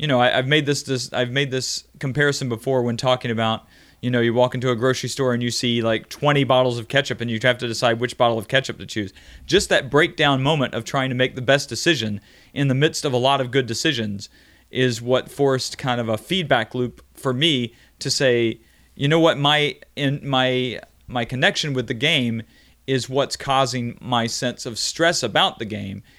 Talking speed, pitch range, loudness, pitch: 220 wpm, 120-140 Hz, -21 LUFS, 125 Hz